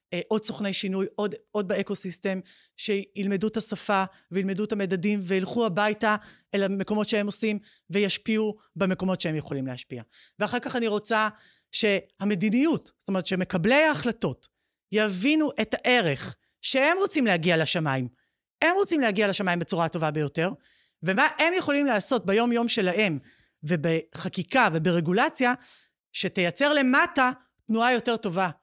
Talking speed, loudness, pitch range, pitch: 130 wpm, -25 LUFS, 185-230 Hz, 205 Hz